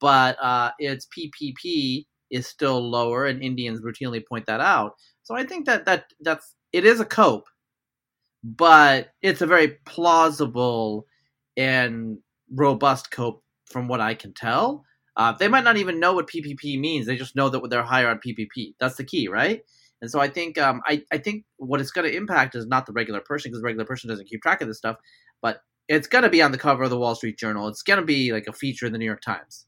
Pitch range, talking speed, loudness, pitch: 120-150 Hz, 220 wpm, -22 LUFS, 130 Hz